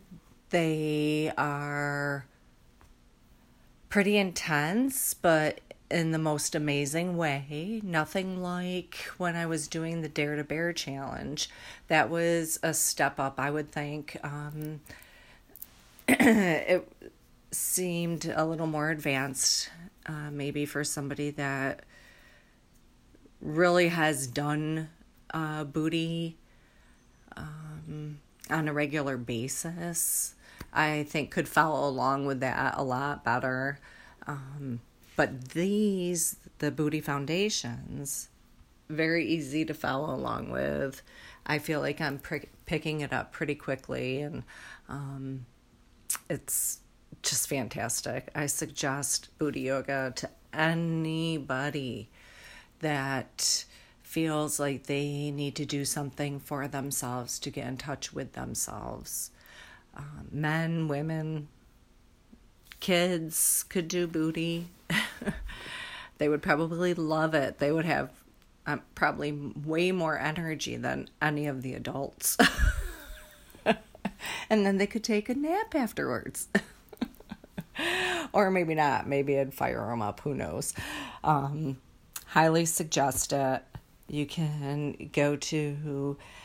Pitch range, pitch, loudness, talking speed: 140-165 Hz, 150 Hz, -30 LUFS, 110 wpm